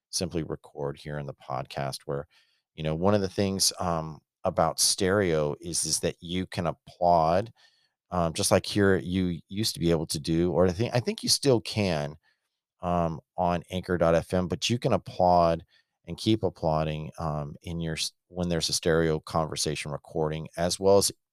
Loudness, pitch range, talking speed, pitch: -27 LUFS, 80-95 Hz, 175 wpm, 85 Hz